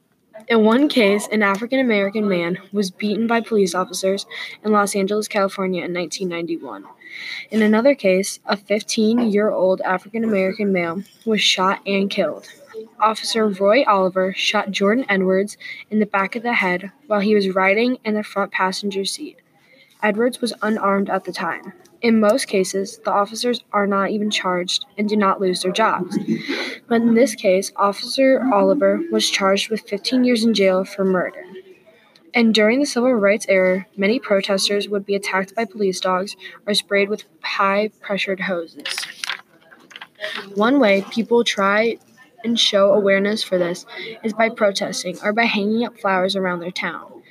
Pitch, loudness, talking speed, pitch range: 200 Hz, -19 LUFS, 160 wpm, 190-220 Hz